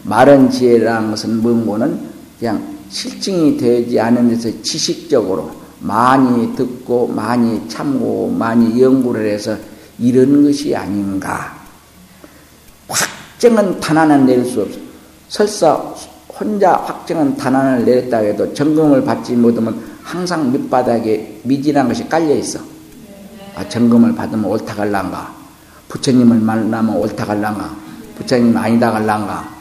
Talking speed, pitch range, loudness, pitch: 265 characters per minute, 110-140 Hz, -14 LUFS, 120 Hz